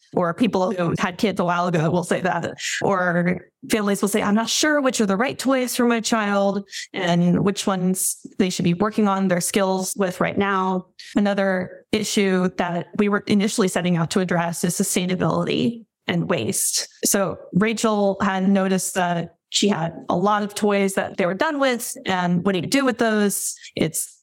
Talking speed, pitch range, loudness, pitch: 190 wpm, 185-215 Hz, -21 LUFS, 200 Hz